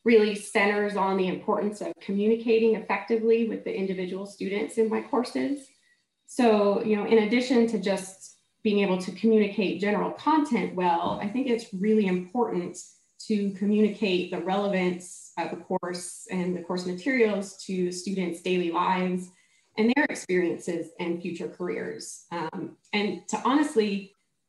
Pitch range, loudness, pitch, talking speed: 185-225 Hz, -27 LUFS, 200 Hz, 145 wpm